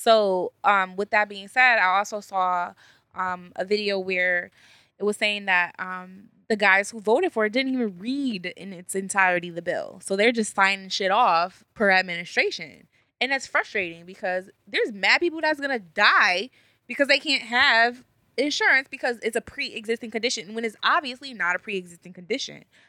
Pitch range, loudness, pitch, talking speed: 185-245 Hz, -23 LUFS, 210 Hz, 180 wpm